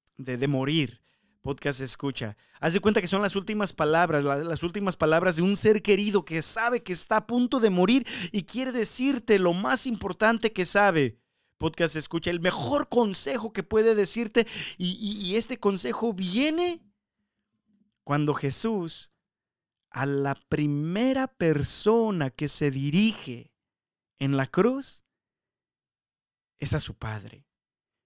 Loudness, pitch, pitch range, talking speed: -26 LUFS, 185 Hz, 145-220 Hz, 140 wpm